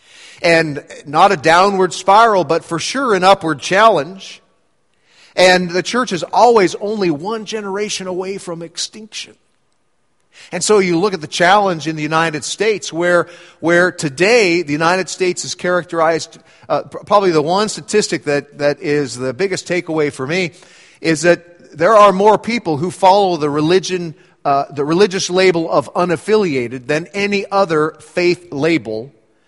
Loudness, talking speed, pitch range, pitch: -15 LUFS, 155 wpm, 160-195 Hz, 175 Hz